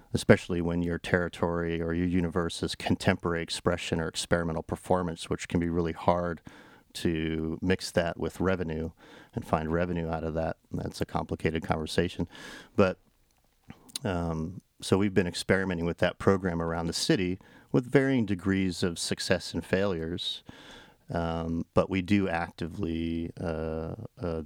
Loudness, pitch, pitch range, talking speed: -30 LUFS, 85 Hz, 85-95 Hz, 145 wpm